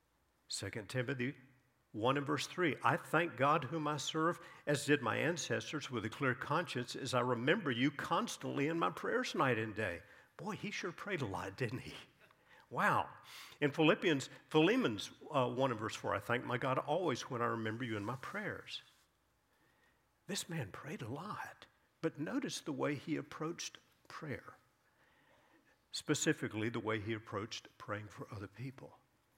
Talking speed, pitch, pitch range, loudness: 165 wpm, 130 Hz, 115-150 Hz, -38 LUFS